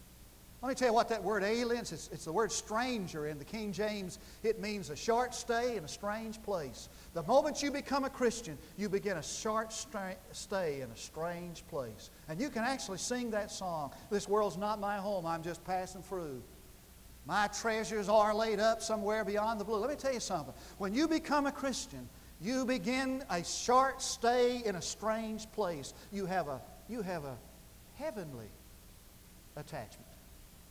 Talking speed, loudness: 185 wpm, -35 LUFS